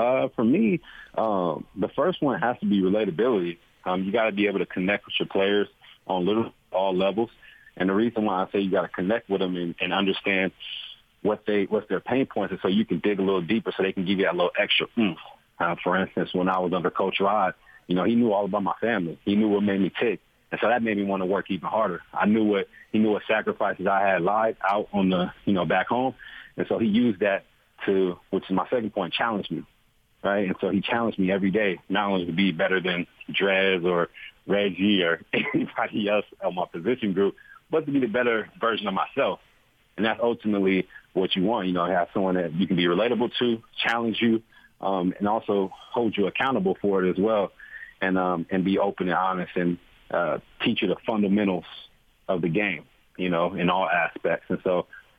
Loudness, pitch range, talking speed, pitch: -25 LUFS, 90-105 Hz, 230 wpm, 95 Hz